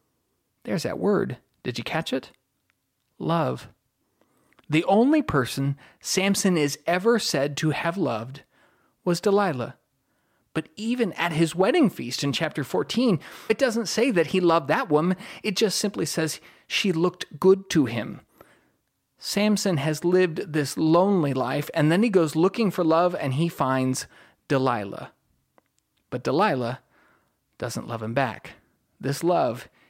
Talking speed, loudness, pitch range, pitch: 140 wpm, -24 LUFS, 145-195 Hz, 170 Hz